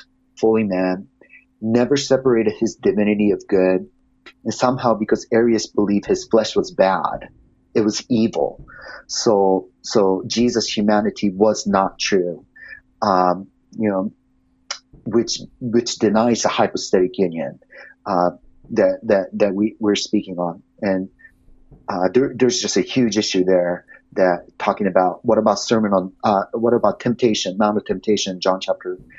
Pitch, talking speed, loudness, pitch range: 105 Hz, 140 wpm, -19 LUFS, 95-115 Hz